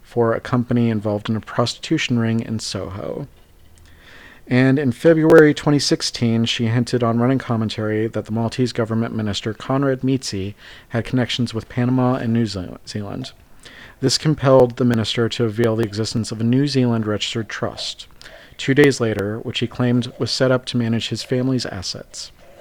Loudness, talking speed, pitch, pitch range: -19 LUFS, 165 wpm, 120 Hz, 110-130 Hz